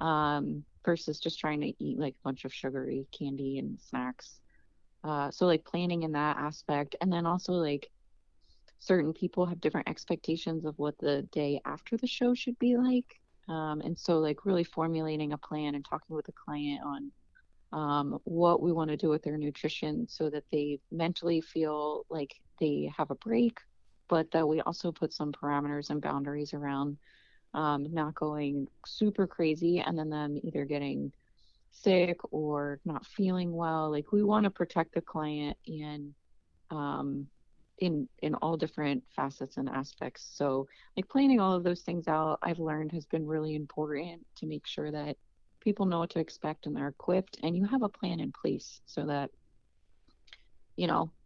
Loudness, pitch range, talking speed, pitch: -33 LUFS, 145-175 Hz, 175 wpm, 155 Hz